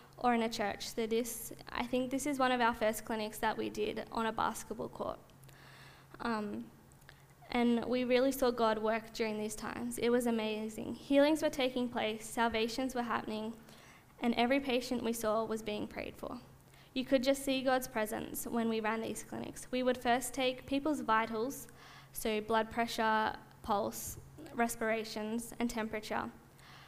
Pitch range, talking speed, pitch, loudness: 220-255 Hz, 165 wpm, 235 Hz, -35 LUFS